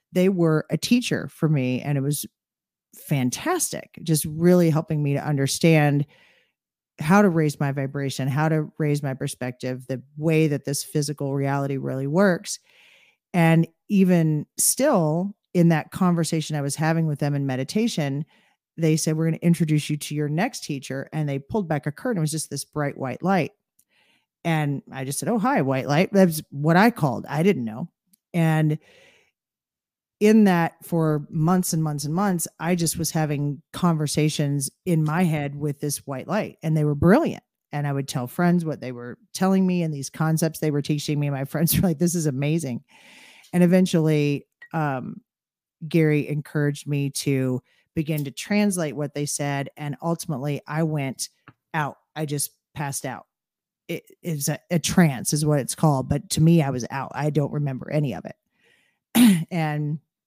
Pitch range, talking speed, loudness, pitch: 145-170 Hz, 180 wpm, -23 LUFS, 155 Hz